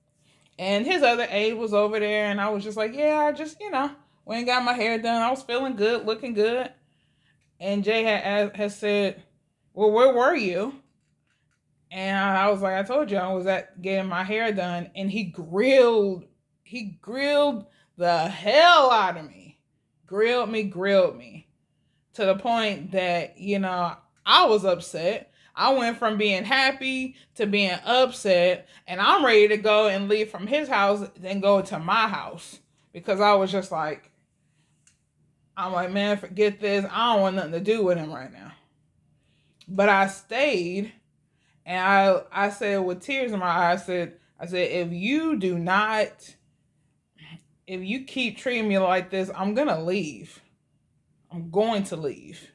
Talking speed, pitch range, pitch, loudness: 175 wpm, 180-220 Hz, 200 Hz, -23 LUFS